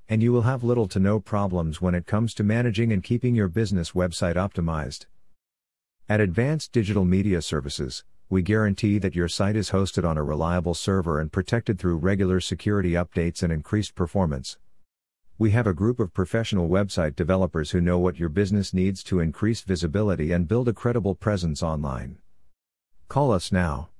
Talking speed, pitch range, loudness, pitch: 175 wpm, 85-105 Hz, -24 LUFS, 95 Hz